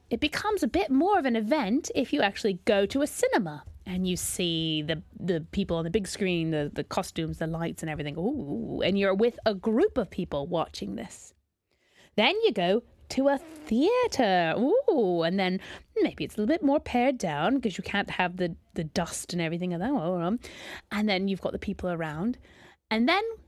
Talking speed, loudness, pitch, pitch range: 205 wpm, -28 LUFS, 205 Hz, 175-280 Hz